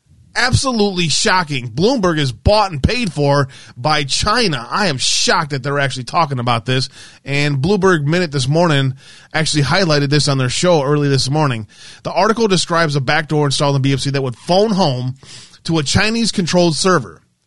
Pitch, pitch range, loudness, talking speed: 150 Hz, 135-175 Hz, -15 LUFS, 170 wpm